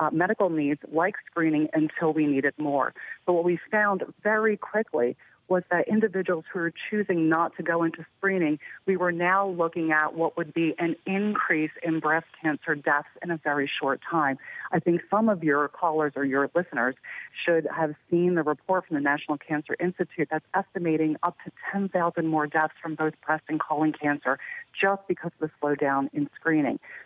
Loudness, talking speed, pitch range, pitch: -26 LUFS, 185 wpm, 155-180 Hz, 165 Hz